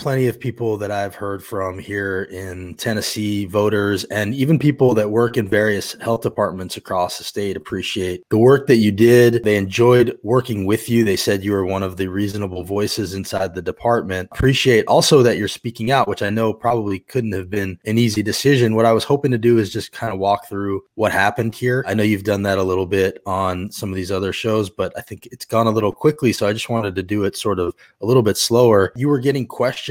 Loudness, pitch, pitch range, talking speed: -18 LUFS, 105 Hz, 95-120 Hz, 235 wpm